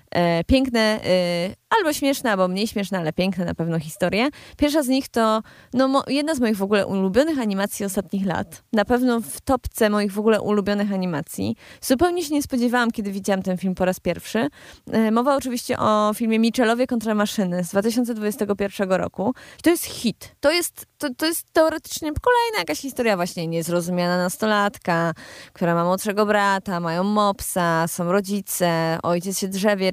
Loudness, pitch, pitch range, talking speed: -22 LUFS, 210 Hz, 185-250 Hz, 165 wpm